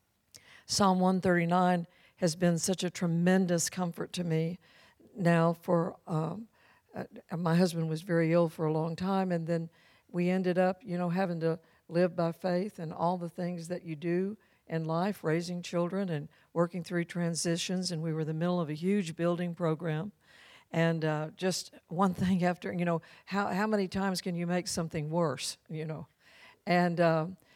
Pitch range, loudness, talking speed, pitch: 165-185 Hz, -31 LUFS, 180 wpm, 175 Hz